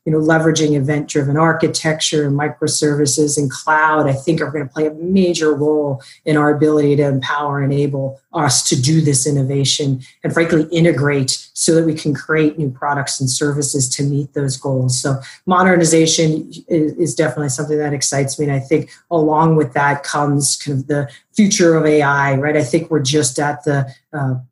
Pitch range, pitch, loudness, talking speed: 140-155 Hz, 150 Hz, -16 LUFS, 185 wpm